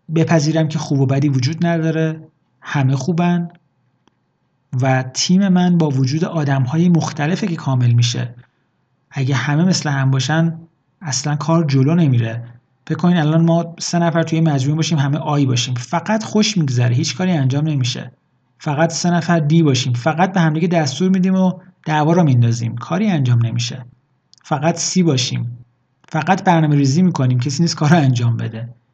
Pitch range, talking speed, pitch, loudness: 130-170 Hz, 160 wpm, 155 Hz, -16 LUFS